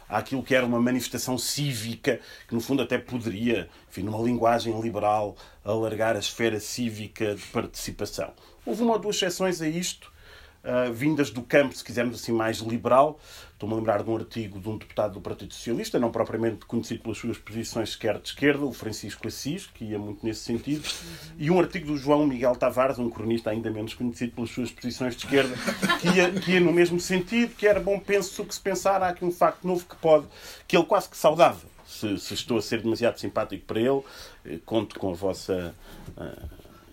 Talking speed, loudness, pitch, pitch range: 200 wpm, -26 LUFS, 120 Hz, 110-150 Hz